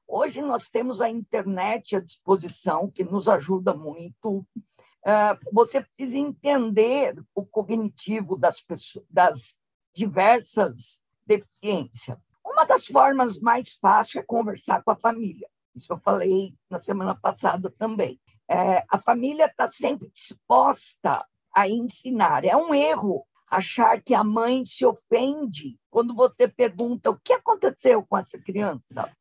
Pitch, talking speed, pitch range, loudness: 220 Hz, 130 wpm, 190-250 Hz, -23 LUFS